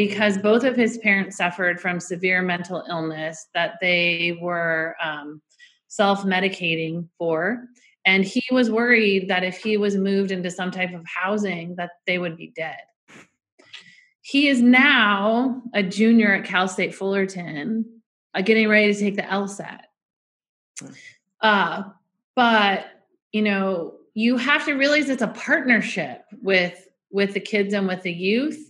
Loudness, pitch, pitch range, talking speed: -21 LUFS, 195 Hz, 180-225 Hz, 145 wpm